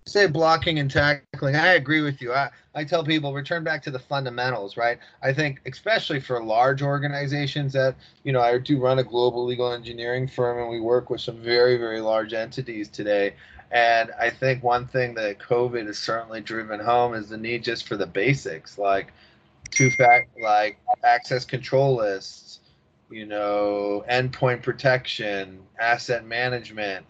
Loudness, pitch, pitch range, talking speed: -23 LUFS, 125 Hz, 115-140 Hz, 170 wpm